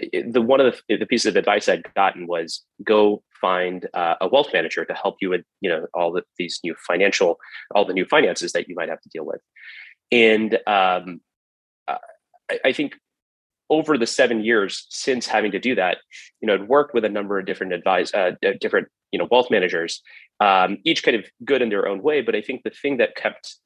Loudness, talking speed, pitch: -21 LUFS, 215 wpm, 110 Hz